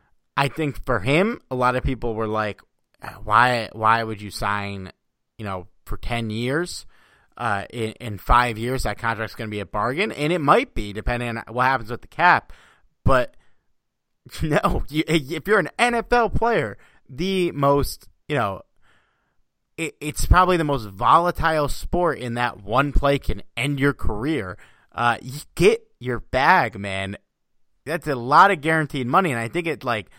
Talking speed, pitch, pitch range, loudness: 175 wpm, 125 Hz, 110-155 Hz, -22 LUFS